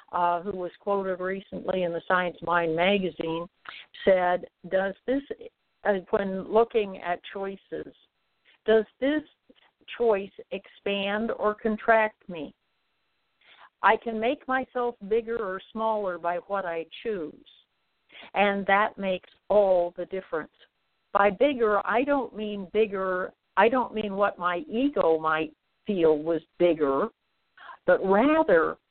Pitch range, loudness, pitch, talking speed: 180-220 Hz, -26 LUFS, 200 Hz, 125 wpm